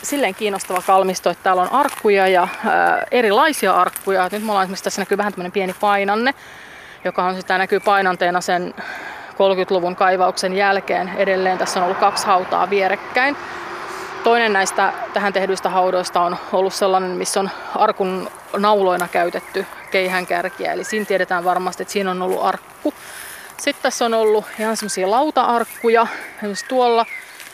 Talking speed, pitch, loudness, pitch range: 150 wpm, 195 Hz, -18 LUFS, 185-215 Hz